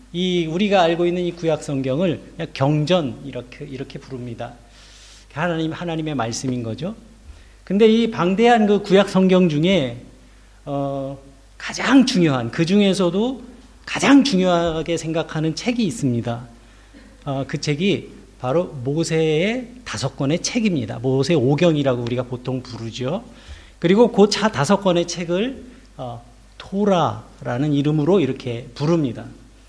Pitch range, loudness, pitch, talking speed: 125-185 Hz, -19 LUFS, 155 Hz, 275 characters per minute